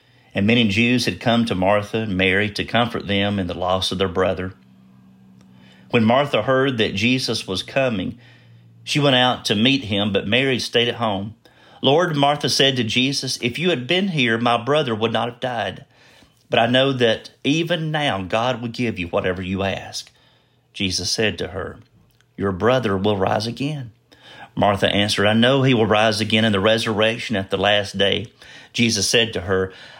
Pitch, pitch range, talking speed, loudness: 110 Hz, 100-125 Hz, 185 wpm, -19 LUFS